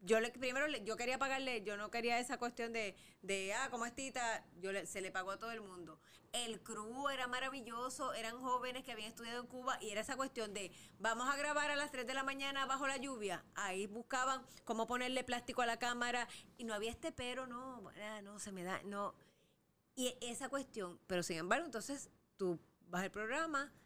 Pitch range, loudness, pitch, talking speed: 210-260 Hz, -42 LUFS, 235 Hz, 215 wpm